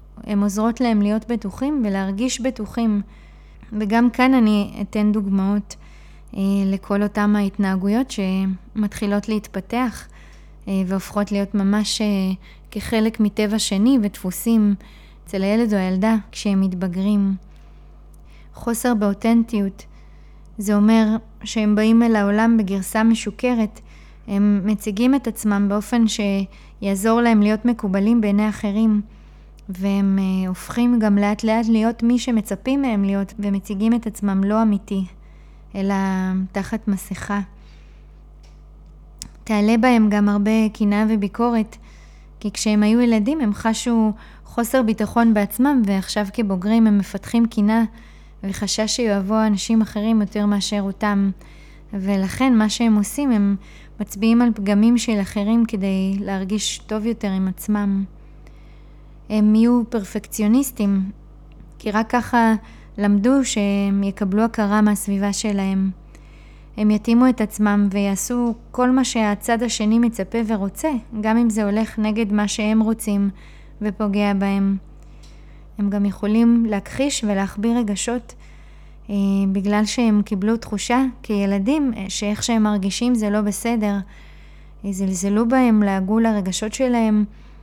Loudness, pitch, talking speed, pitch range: -20 LUFS, 210 Hz, 115 wpm, 200-225 Hz